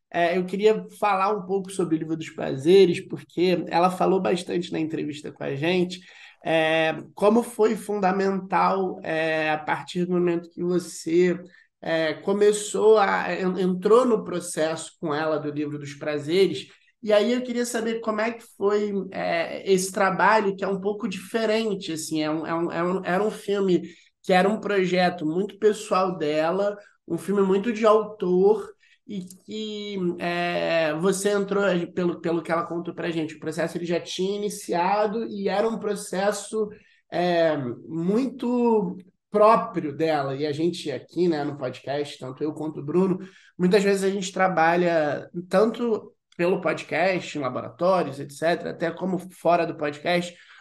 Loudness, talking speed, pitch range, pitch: -24 LUFS, 160 wpm, 165-205 Hz, 180 Hz